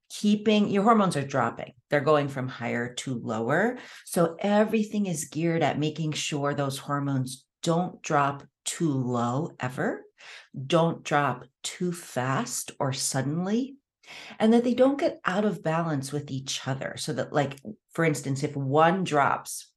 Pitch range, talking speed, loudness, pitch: 135-195 Hz, 150 wpm, -27 LUFS, 155 Hz